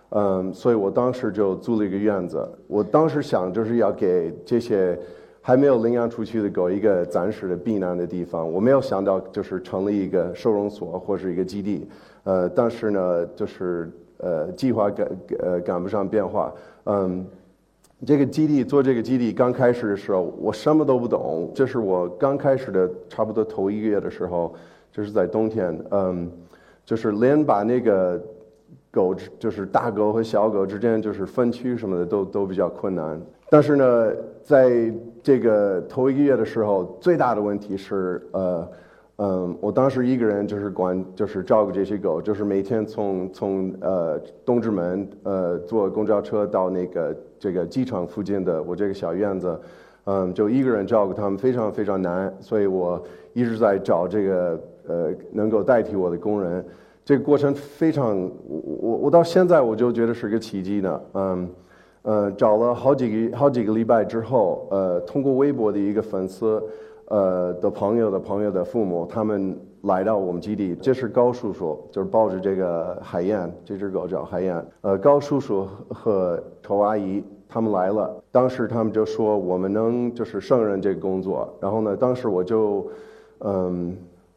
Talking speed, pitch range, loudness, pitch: 265 characters per minute, 95-120 Hz, -23 LUFS, 105 Hz